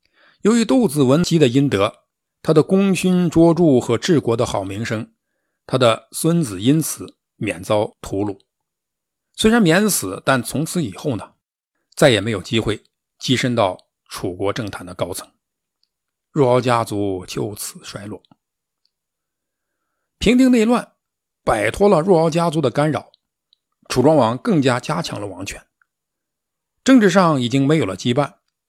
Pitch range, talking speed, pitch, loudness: 115-185 Hz, 210 characters per minute, 150 Hz, -18 LUFS